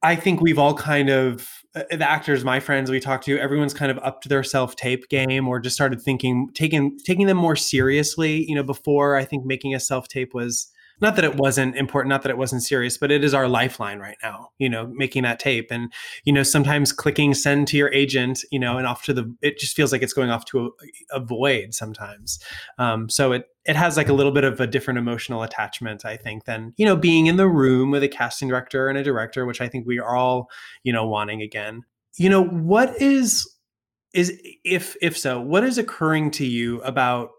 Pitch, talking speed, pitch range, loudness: 135 Hz, 230 wpm, 125-145 Hz, -21 LUFS